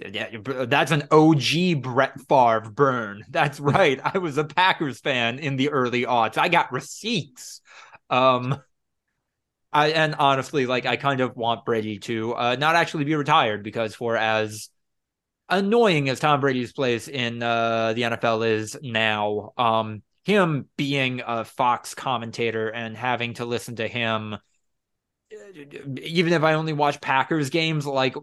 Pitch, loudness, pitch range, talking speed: 130 Hz, -22 LUFS, 115-150 Hz, 150 wpm